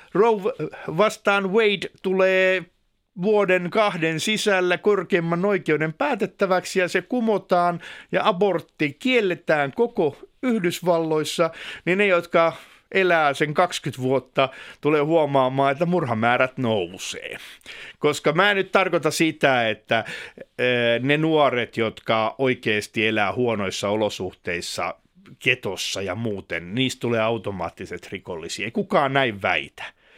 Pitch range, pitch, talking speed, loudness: 130-190 Hz, 165 Hz, 110 wpm, -22 LUFS